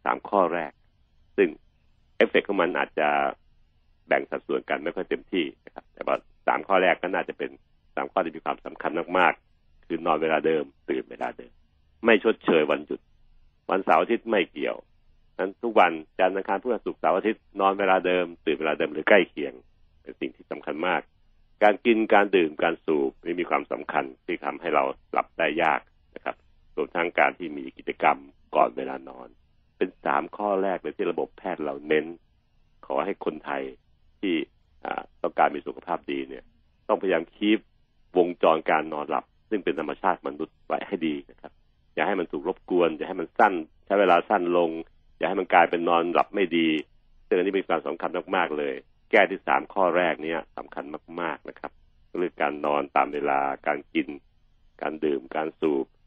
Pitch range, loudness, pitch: 70-90 Hz, -26 LUFS, 80 Hz